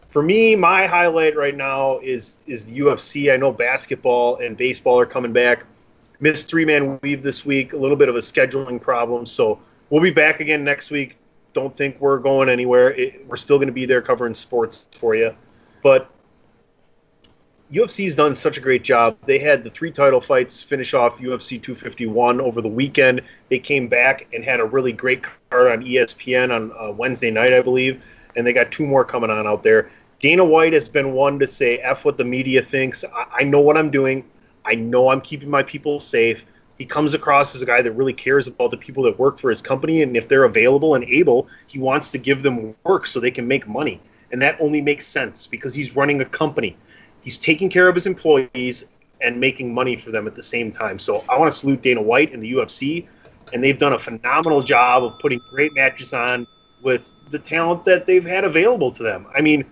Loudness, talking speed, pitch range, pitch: -18 LUFS, 215 wpm, 125-155 Hz, 135 Hz